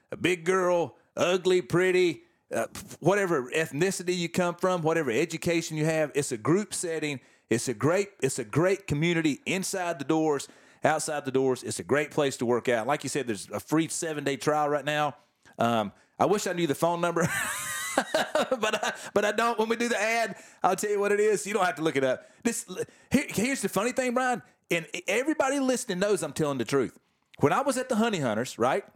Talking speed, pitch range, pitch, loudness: 220 wpm, 150-205 Hz, 175 Hz, -27 LUFS